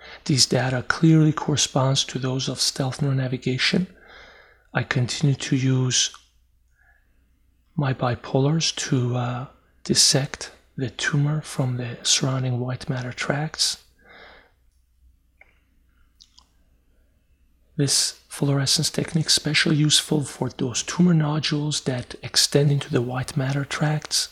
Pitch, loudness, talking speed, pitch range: 130 Hz, -22 LUFS, 110 wpm, 100-150 Hz